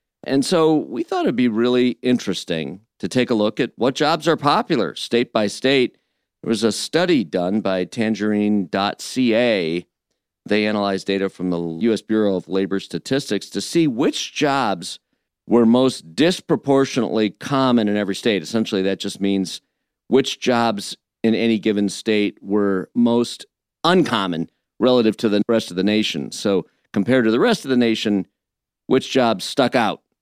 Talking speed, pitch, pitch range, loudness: 160 wpm, 110 Hz, 100-125 Hz, -20 LUFS